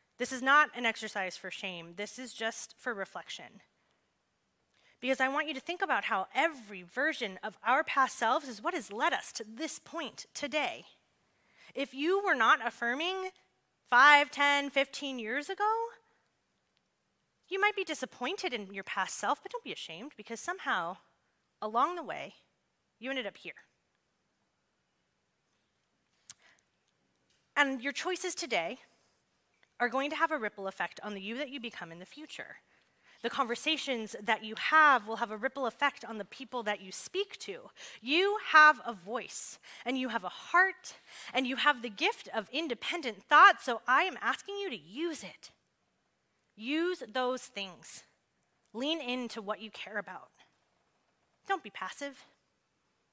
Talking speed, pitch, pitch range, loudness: 160 wpm, 265 Hz, 225-315 Hz, -31 LUFS